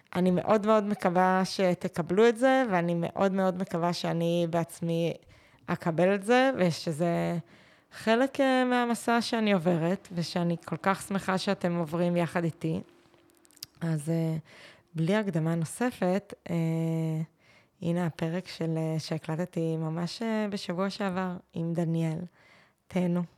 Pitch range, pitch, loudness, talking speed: 165-195 Hz, 175 Hz, -29 LUFS, 110 wpm